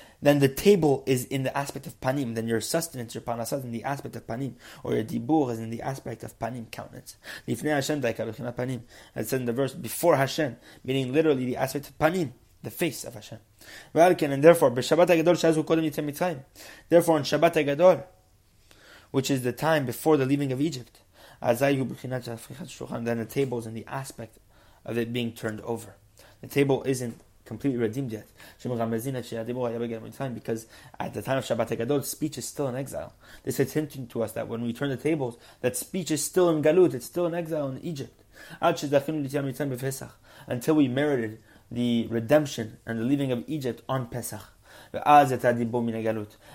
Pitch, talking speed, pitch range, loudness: 130 Hz, 160 wpm, 115-145 Hz, -26 LUFS